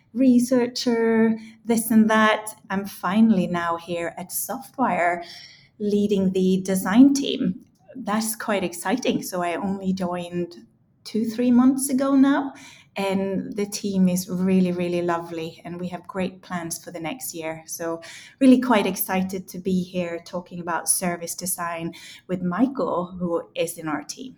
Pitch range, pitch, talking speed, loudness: 175-220 Hz, 190 Hz, 150 wpm, -23 LUFS